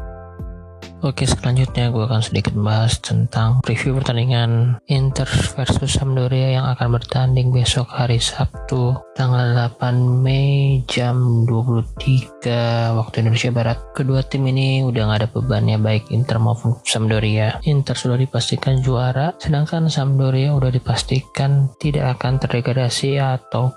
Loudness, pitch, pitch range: -18 LUFS, 125 Hz, 115-130 Hz